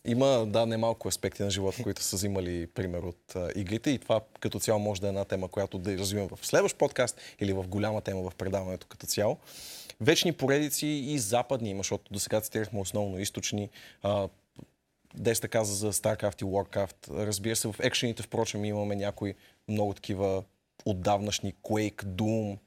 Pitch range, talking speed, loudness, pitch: 100-110 Hz, 175 wpm, -31 LUFS, 105 Hz